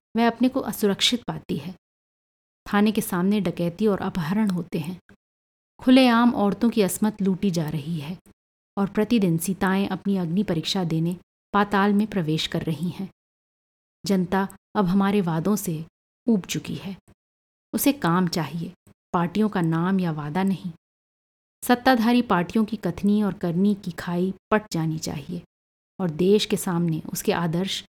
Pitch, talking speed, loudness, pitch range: 190 Hz, 150 wpm, -23 LUFS, 175-210 Hz